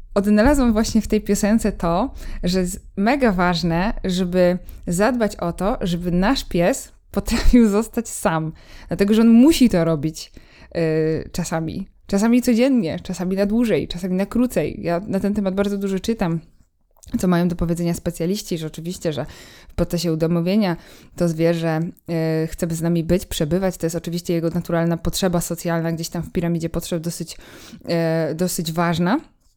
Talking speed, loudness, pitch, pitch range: 160 wpm, -20 LUFS, 180 Hz, 170-205 Hz